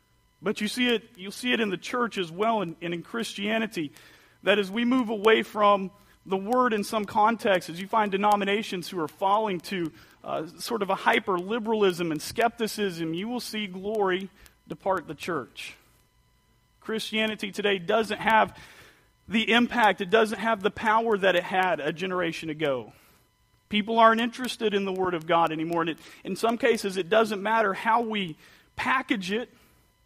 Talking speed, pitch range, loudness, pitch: 175 wpm, 185-225 Hz, -26 LUFS, 205 Hz